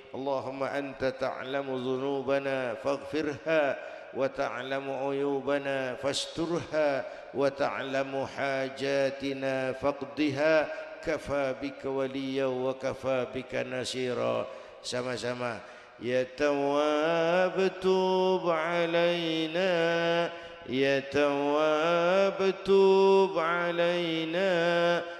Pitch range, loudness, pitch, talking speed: 135-170 Hz, -29 LUFS, 140 Hz, 60 wpm